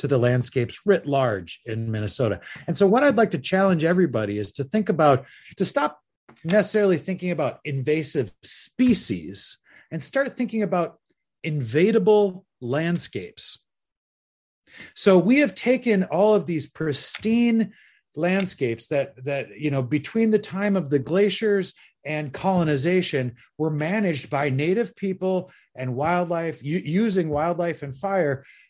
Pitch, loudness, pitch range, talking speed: 170 Hz, -23 LUFS, 140-200 Hz, 135 wpm